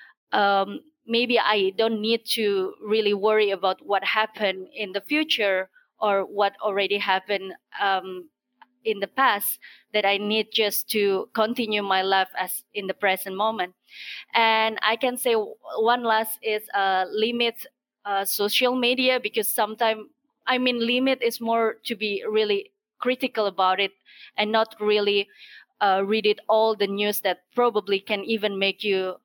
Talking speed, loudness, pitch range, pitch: 155 wpm, -24 LUFS, 200-230 Hz, 215 Hz